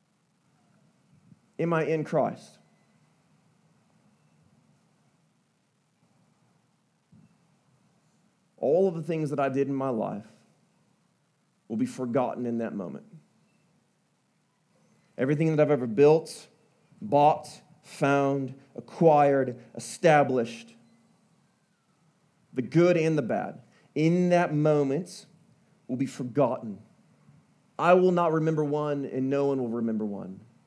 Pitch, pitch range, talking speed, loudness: 150 Hz, 135-170 Hz, 100 wpm, -26 LUFS